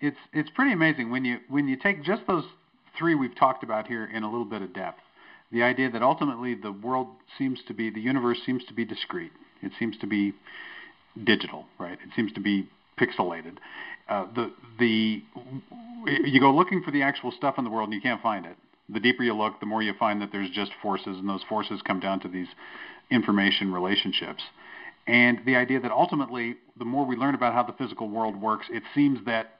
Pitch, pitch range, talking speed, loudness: 120 Hz, 105-130 Hz, 215 wpm, -26 LUFS